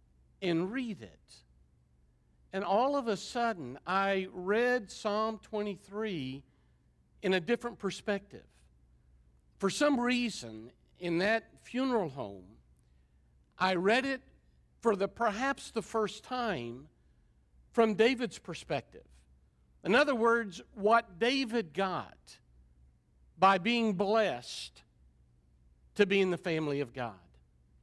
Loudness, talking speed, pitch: -32 LUFS, 110 wpm, 190 Hz